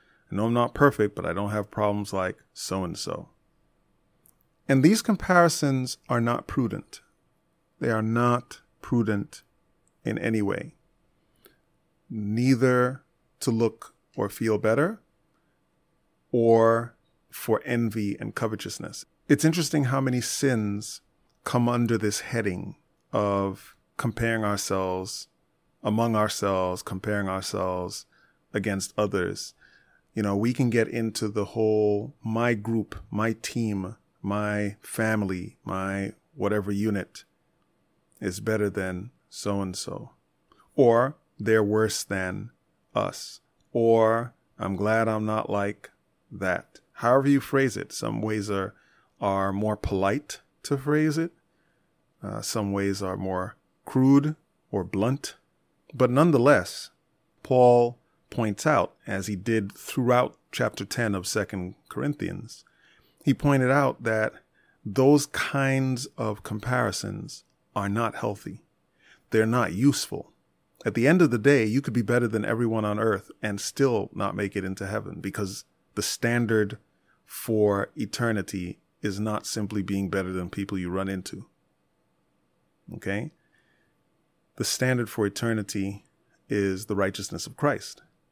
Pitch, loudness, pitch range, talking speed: 110 Hz, -26 LUFS, 100-120 Hz, 125 wpm